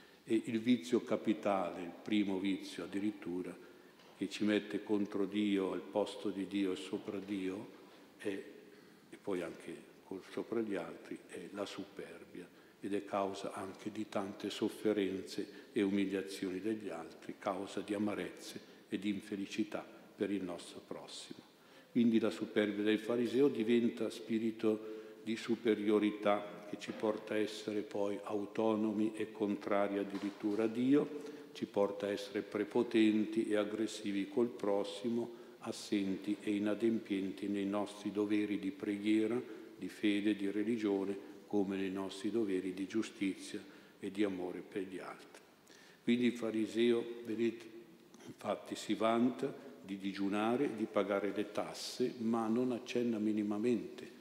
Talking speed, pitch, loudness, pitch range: 135 wpm, 105 Hz, -37 LUFS, 100-110 Hz